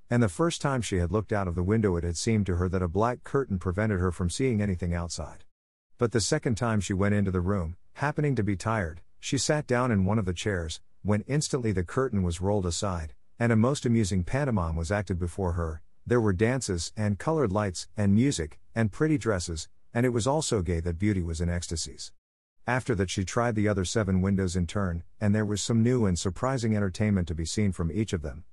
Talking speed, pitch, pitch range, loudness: 230 wpm, 100 Hz, 90-115 Hz, -28 LUFS